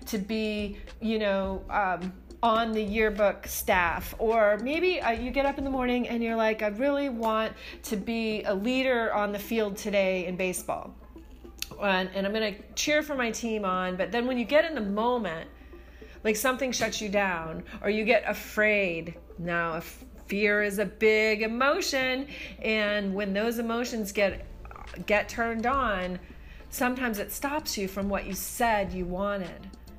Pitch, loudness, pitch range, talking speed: 215 Hz, -28 LUFS, 200-235 Hz, 170 wpm